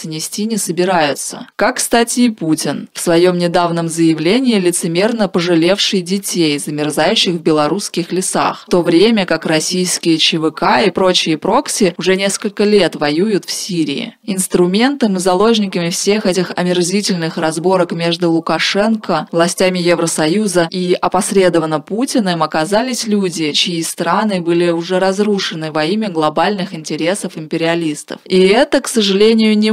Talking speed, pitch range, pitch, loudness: 130 wpm, 165-205 Hz, 180 Hz, -14 LUFS